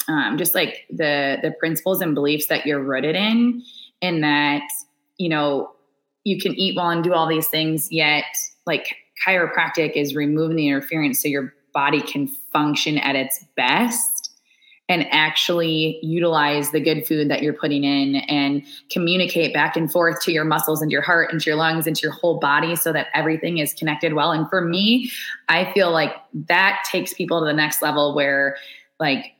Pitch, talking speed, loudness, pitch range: 155 Hz, 185 wpm, -20 LUFS, 145-170 Hz